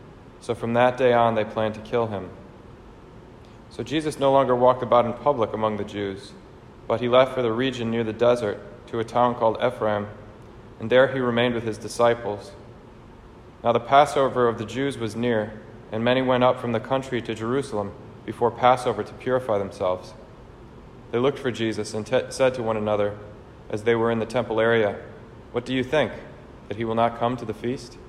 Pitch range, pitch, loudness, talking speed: 110-125 Hz, 115 Hz, -23 LUFS, 200 wpm